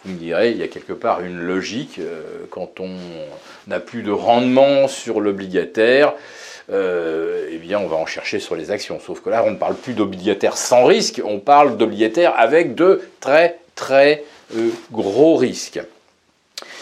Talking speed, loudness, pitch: 170 wpm, -17 LUFS, 140 Hz